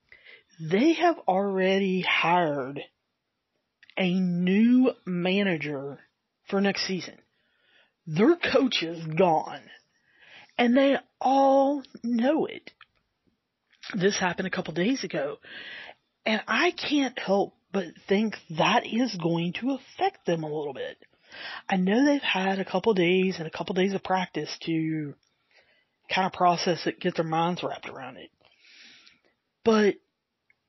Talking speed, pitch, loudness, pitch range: 130 wpm, 195 Hz, -26 LUFS, 175-255 Hz